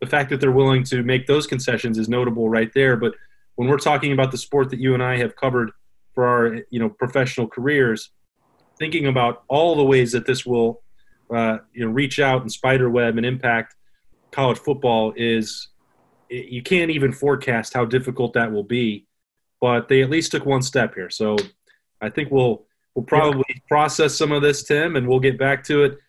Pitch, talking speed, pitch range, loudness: 130 Hz, 200 wpm, 120-140 Hz, -20 LUFS